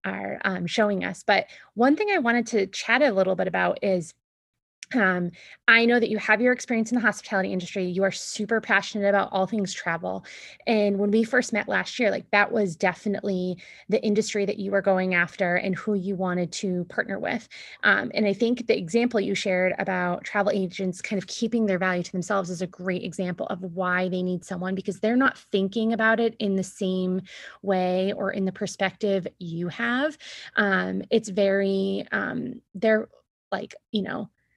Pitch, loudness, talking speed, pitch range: 195 Hz, -25 LUFS, 195 wpm, 185-220 Hz